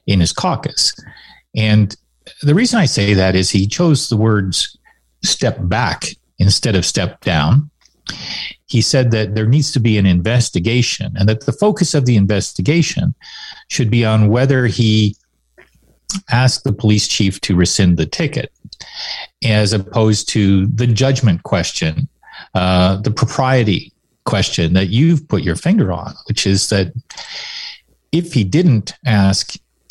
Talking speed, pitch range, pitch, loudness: 145 wpm, 95-130 Hz, 110 Hz, -15 LUFS